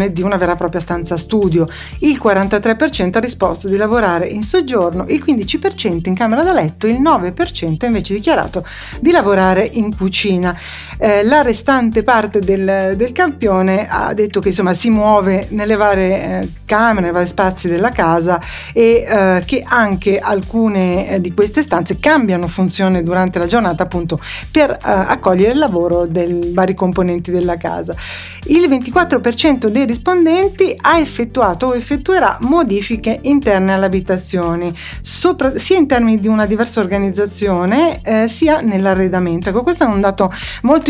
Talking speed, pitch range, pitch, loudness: 155 wpm, 185-245 Hz, 205 Hz, -14 LUFS